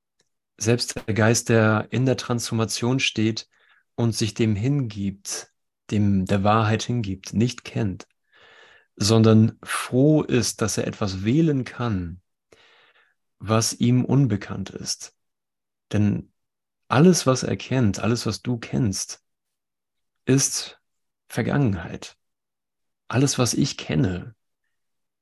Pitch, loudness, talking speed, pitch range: 115 Hz, -22 LUFS, 105 wpm, 105-125 Hz